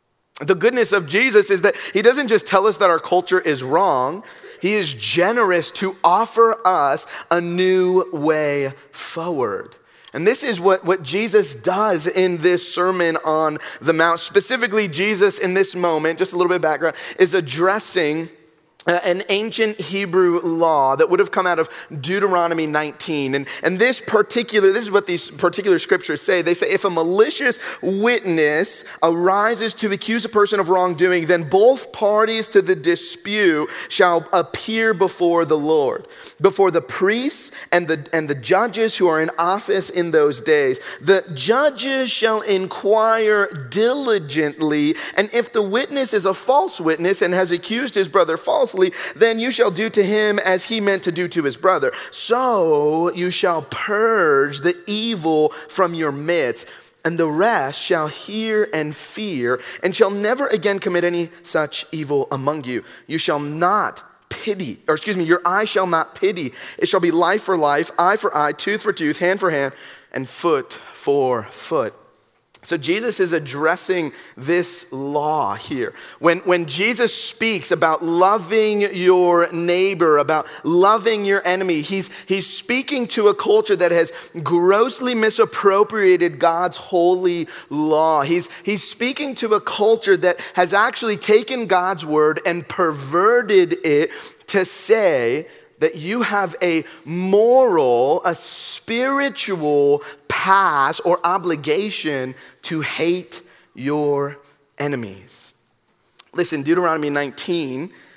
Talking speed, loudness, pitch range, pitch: 150 wpm, -18 LUFS, 165-220 Hz, 185 Hz